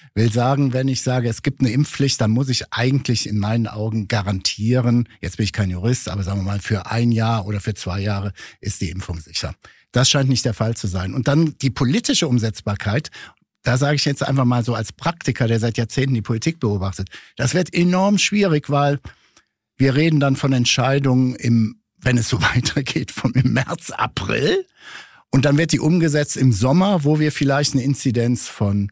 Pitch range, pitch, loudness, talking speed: 110-140 Hz, 125 Hz, -19 LUFS, 200 wpm